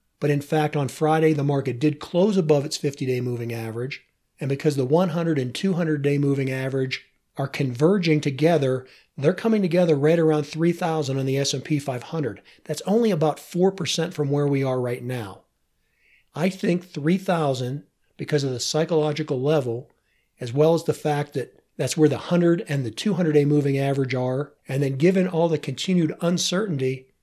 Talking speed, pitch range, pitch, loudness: 175 wpm, 135-165 Hz, 150 Hz, -23 LUFS